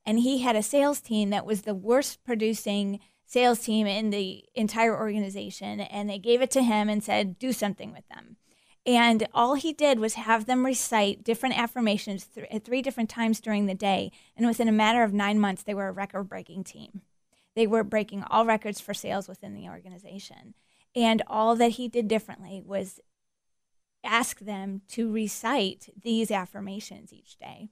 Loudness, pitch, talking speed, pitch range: -26 LUFS, 215 Hz, 185 wpm, 200-230 Hz